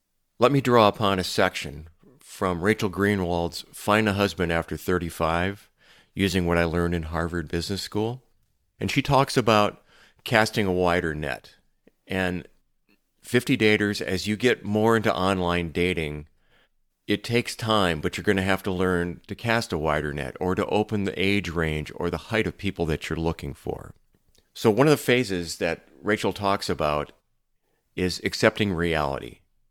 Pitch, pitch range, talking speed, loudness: 95 Hz, 85-105 Hz, 165 wpm, -24 LUFS